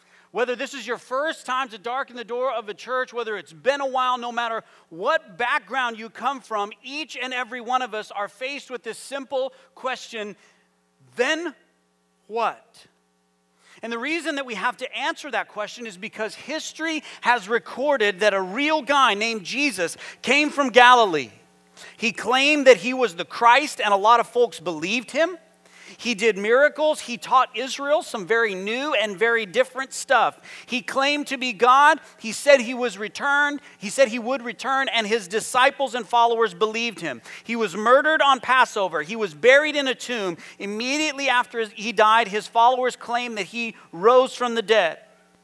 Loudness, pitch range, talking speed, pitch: -22 LUFS, 220-270 Hz, 180 wpm, 240 Hz